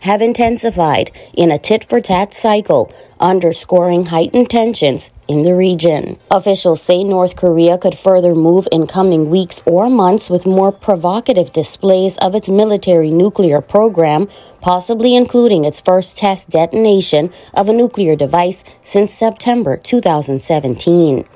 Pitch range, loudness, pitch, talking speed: 170-210 Hz, -12 LUFS, 185 Hz, 135 wpm